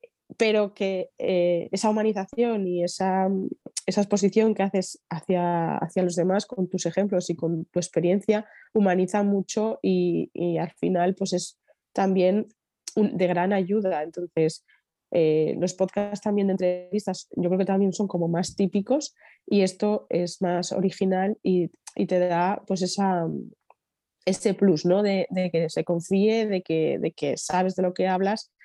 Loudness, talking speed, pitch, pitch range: -25 LUFS, 165 wpm, 190 Hz, 175-205 Hz